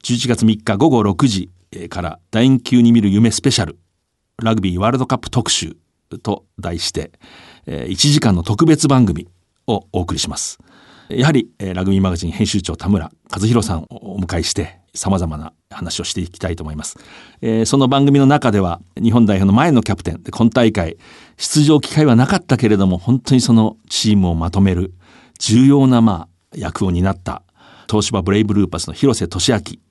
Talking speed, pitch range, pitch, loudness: 335 characters per minute, 90-120 Hz, 105 Hz, -16 LUFS